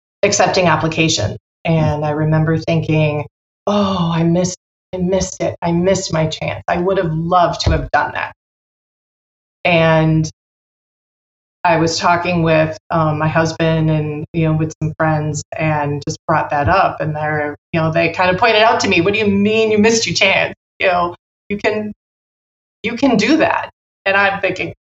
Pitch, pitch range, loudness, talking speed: 165 Hz, 155-190 Hz, -16 LUFS, 175 wpm